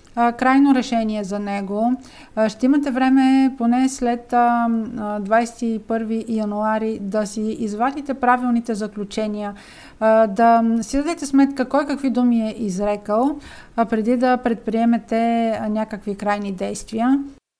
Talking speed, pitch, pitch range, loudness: 105 wpm, 230 Hz, 220-255 Hz, -20 LUFS